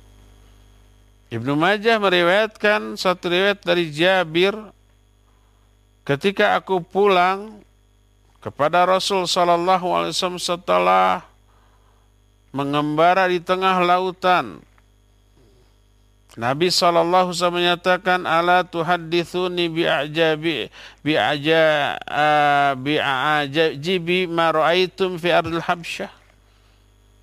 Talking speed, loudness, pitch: 80 wpm, -19 LUFS, 165 Hz